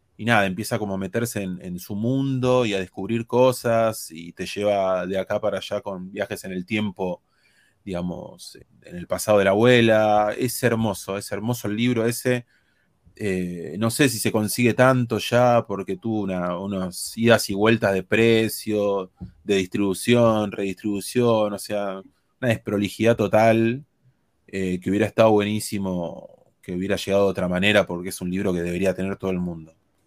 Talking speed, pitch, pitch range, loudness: 170 wpm, 105 Hz, 95-115 Hz, -22 LUFS